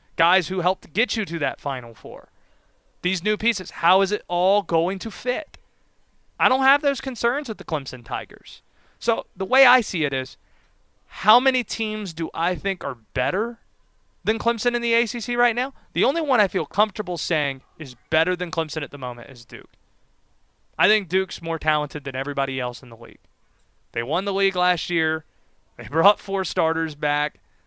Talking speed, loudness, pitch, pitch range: 190 wpm, -22 LUFS, 180 Hz, 150-220 Hz